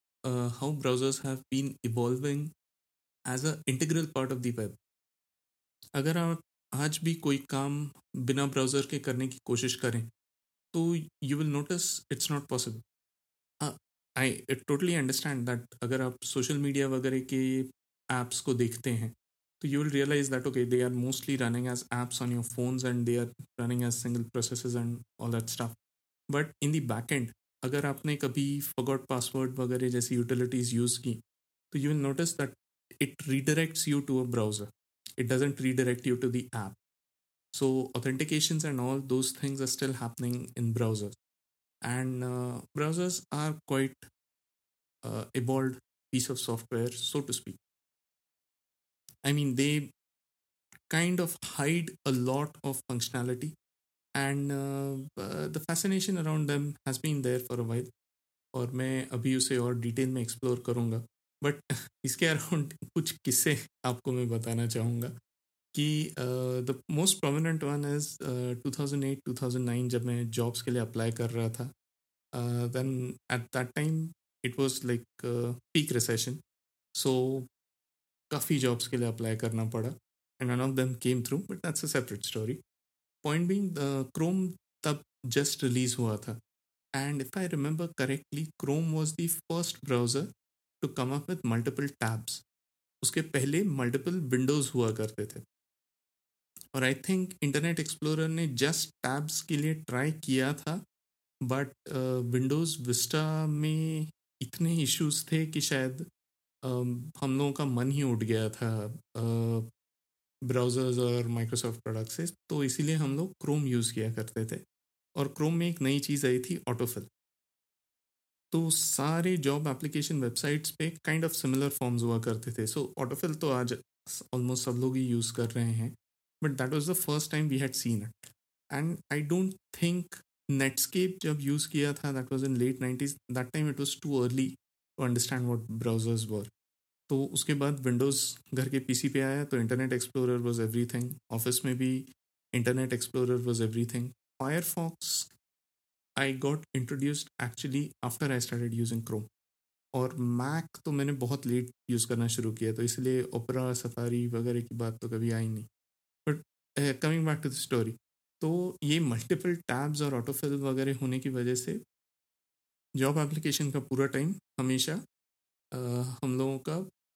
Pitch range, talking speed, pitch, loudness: 120-145 Hz, 155 wpm, 130 Hz, -32 LUFS